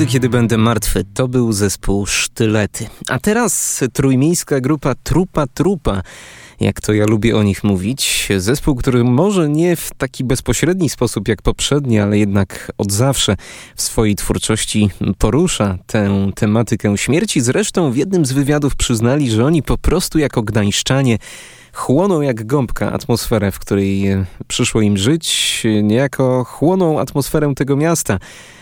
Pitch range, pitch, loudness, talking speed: 105-145 Hz, 120 Hz, -16 LUFS, 140 wpm